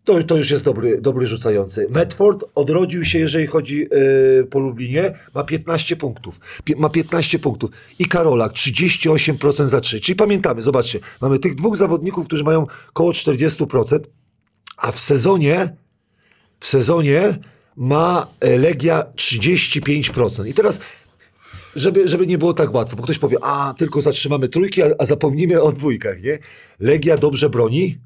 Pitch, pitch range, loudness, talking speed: 155 Hz, 135-170 Hz, -17 LUFS, 150 wpm